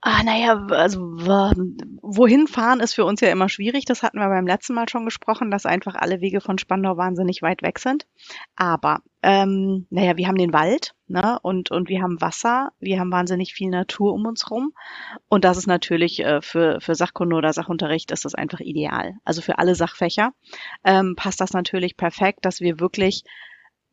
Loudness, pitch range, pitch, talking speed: -21 LUFS, 180-225 Hz, 190 Hz, 190 wpm